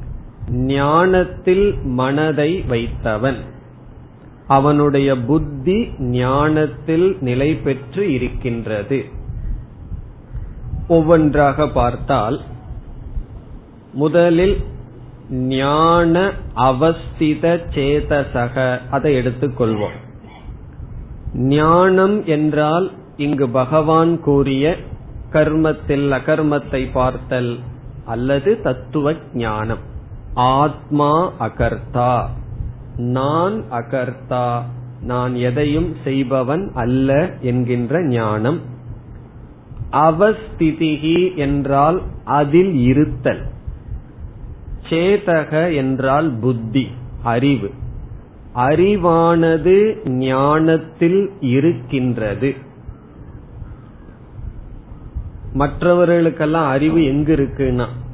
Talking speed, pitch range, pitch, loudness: 55 wpm, 125-155 Hz, 135 Hz, -17 LUFS